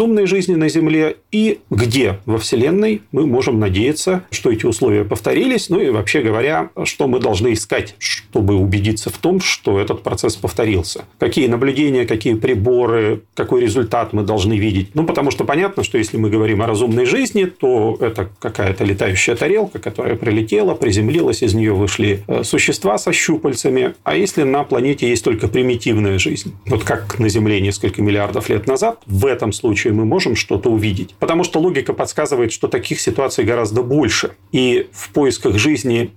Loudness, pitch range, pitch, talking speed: -16 LUFS, 105-150 Hz, 115 Hz, 170 wpm